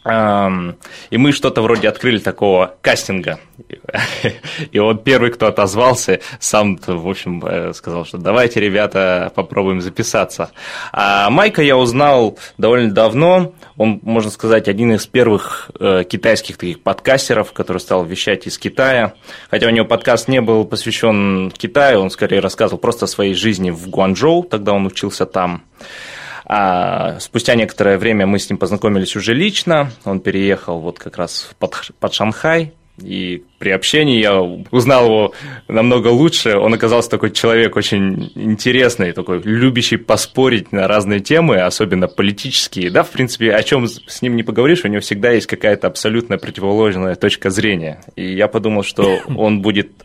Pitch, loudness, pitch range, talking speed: 110 Hz, -14 LUFS, 95-120 Hz, 150 wpm